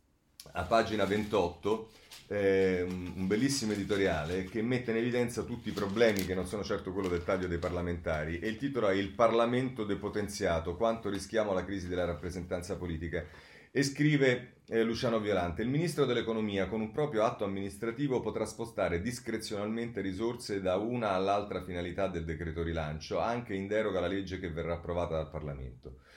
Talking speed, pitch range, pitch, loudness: 165 wpm, 90-115 Hz, 100 Hz, -33 LUFS